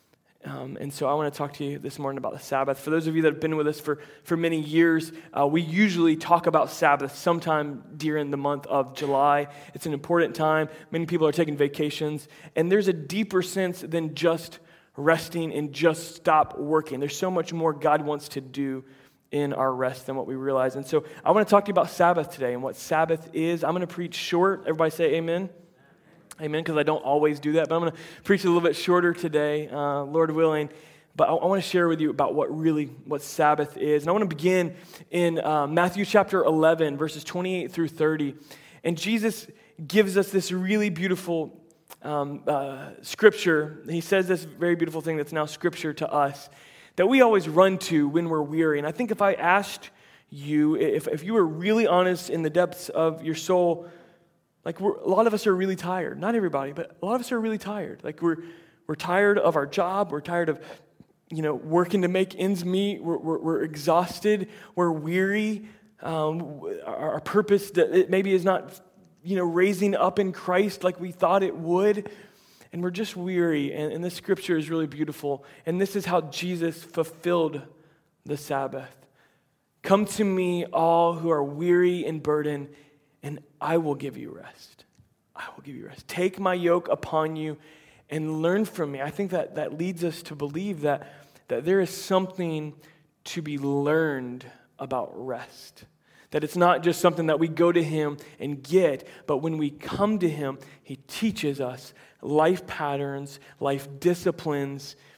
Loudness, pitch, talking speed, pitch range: -25 LUFS, 165 Hz, 195 wpm, 150-180 Hz